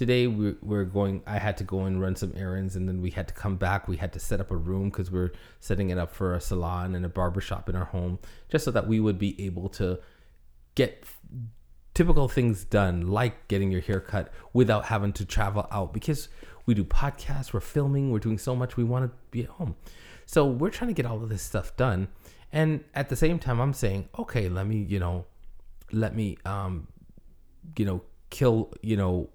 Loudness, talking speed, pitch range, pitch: -29 LUFS, 220 wpm, 90-120 Hz, 100 Hz